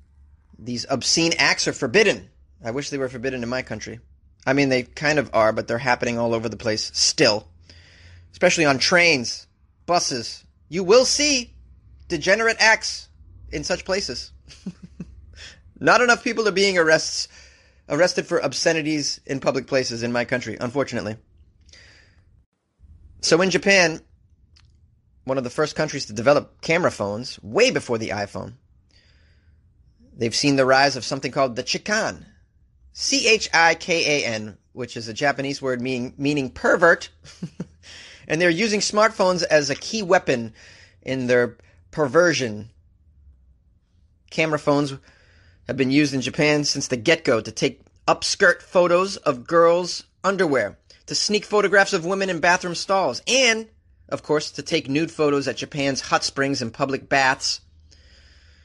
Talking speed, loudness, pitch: 145 wpm, -20 LUFS, 130 Hz